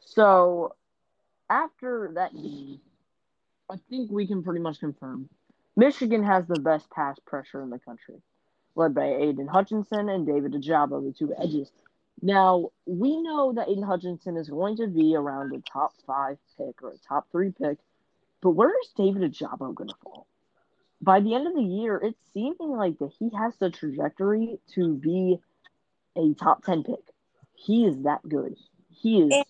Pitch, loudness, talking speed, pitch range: 185 Hz, -26 LUFS, 165 wpm, 150-215 Hz